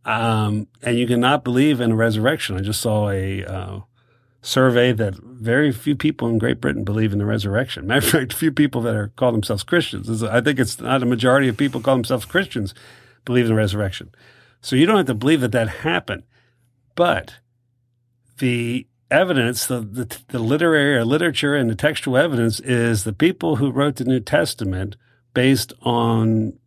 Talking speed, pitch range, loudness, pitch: 190 wpm, 110-130 Hz, -19 LUFS, 120 Hz